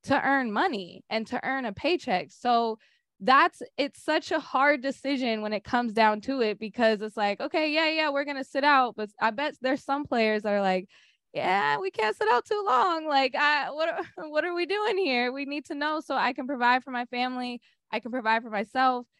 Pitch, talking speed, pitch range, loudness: 265 Hz, 225 wpm, 225-295 Hz, -27 LUFS